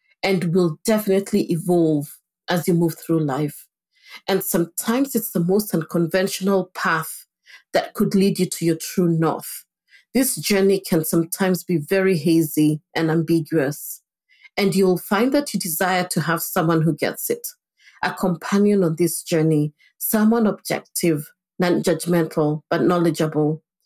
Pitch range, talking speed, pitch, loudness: 165-195 Hz, 140 wpm, 180 Hz, -21 LUFS